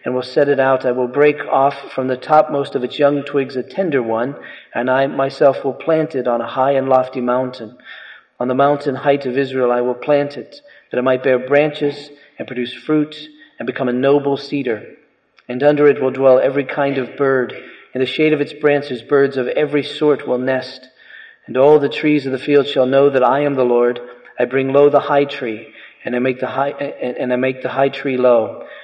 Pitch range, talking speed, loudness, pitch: 125-145 Hz, 225 wpm, -16 LUFS, 135 Hz